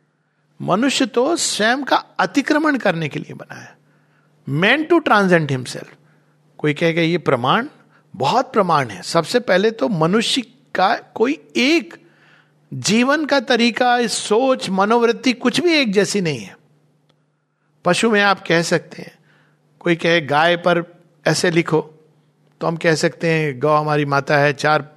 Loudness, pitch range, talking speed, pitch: -17 LUFS, 155-235 Hz, 150 wpm, 175 Hz